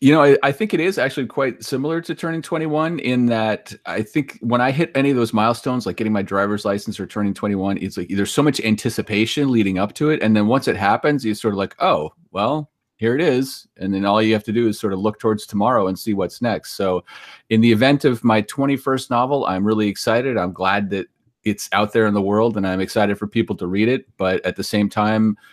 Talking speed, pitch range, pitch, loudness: 250 wpm, 100-130 Hz, 110 Hz, -19 LUFS